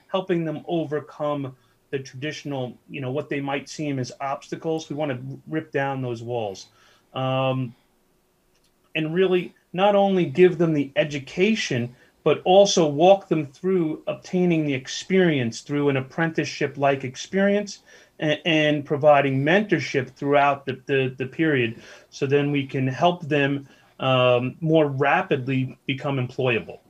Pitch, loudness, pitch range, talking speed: 145 Hz, -23 LUFS, 130-165 Hz, 140 wpm